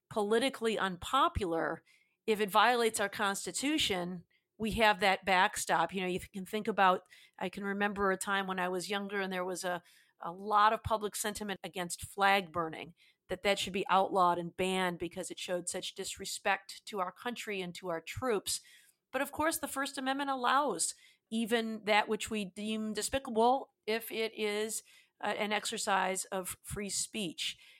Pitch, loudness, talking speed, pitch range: 200 Hz, -33 LUFS, 170 wpm, 185-220 Hz